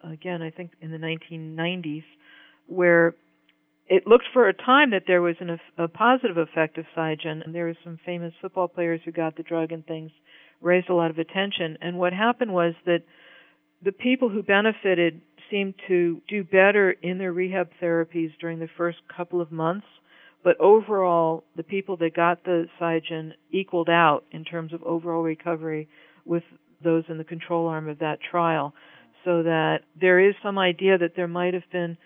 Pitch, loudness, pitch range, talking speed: 170 Hz, -24 LUFS, 165-180 Hz, 185 wpm